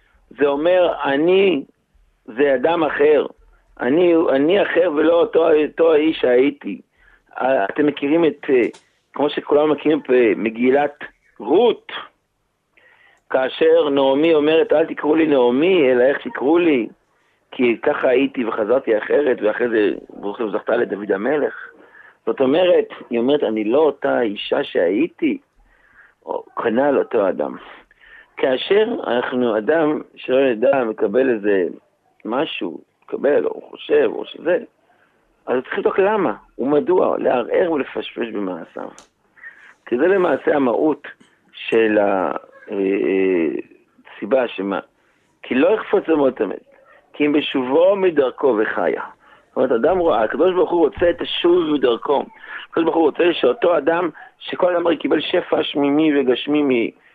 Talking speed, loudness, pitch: 130 wpm, -18 LUFS, 300 Hz